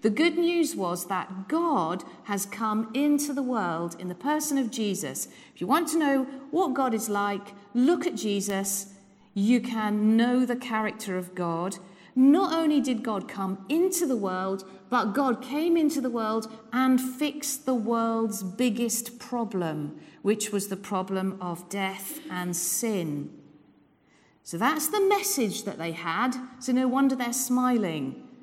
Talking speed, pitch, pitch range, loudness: 160 wpm, 225 Hz, 195-265 Hz, -27 LUFS